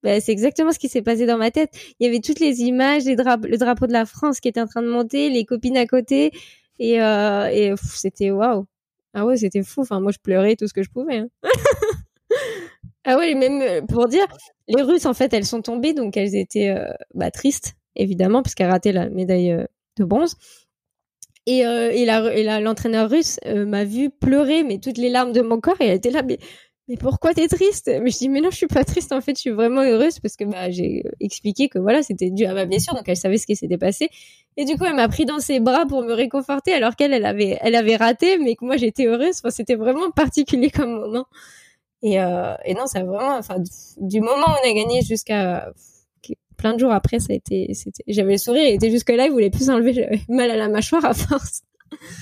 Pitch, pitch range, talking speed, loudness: 240 Hz, 215-275 Hz, 245 wpm, -19 LUFS